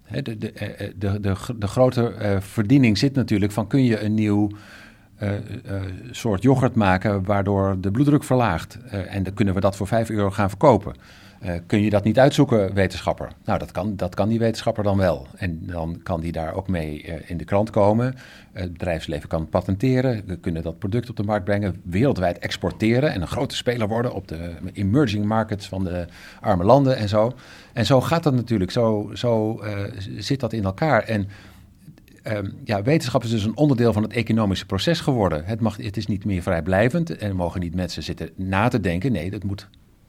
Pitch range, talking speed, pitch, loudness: 95-115 Hz, 200 wpm, 105 Hz, -22 LUFS